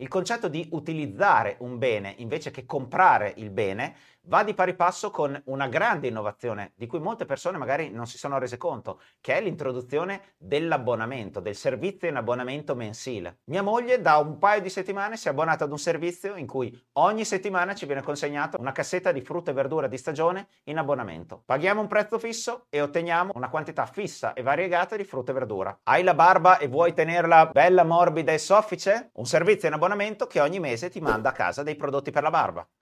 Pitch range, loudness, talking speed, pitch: 135-185 Hz, -25 LUFS, 200 wpm, 160 Hz